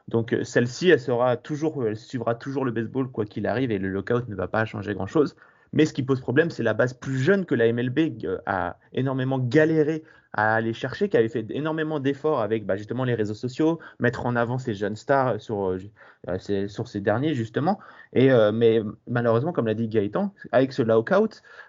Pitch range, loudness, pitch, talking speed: 110-140 Hz, -24 LUFS, 120 Hz, 210 wpm